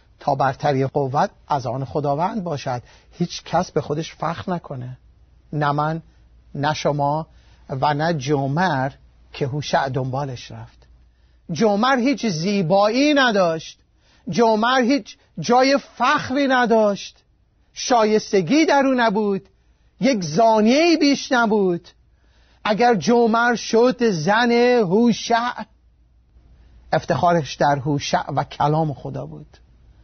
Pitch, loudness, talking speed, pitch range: 170 Hz, -19 LUFS, 105 wpm, 140-230 Hz